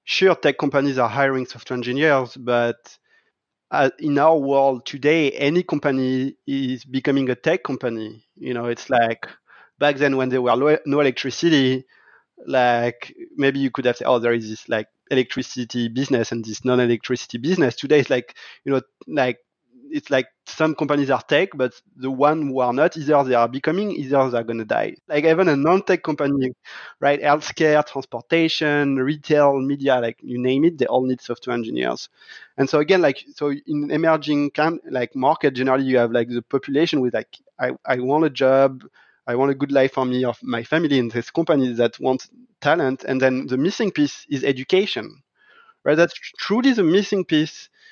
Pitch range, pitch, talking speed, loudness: 125-150 Hz, 135 Hz, 180 wpm, -20 LUFS